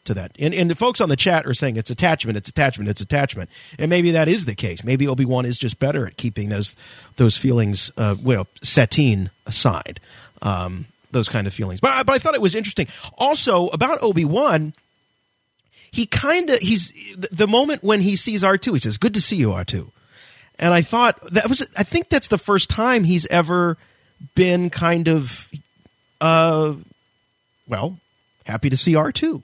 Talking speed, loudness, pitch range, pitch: 185 wpm, -19 LUFS, 115-195 Hz, 155 Hz